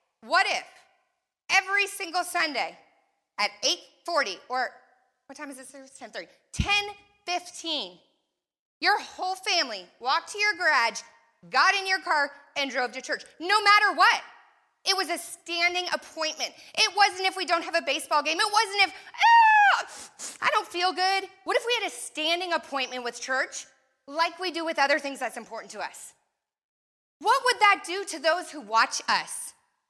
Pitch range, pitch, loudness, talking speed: 285-390 Hz, 345 Hz, -25 LUFS, 165 wpm